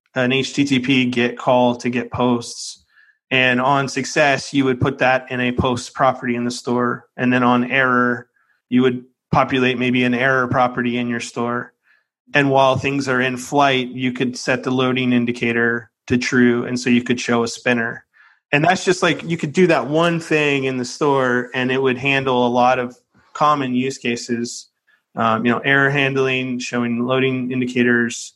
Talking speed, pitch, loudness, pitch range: 185 wpm, 125 Hz, -18 LUFS, 120-135 Hz